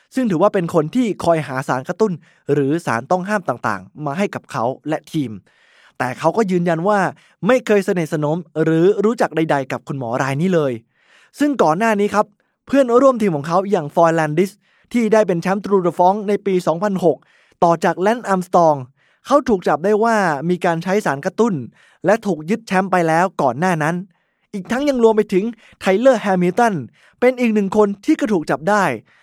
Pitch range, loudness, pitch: 160-210 Hz, -18 LUFS, 185 Hz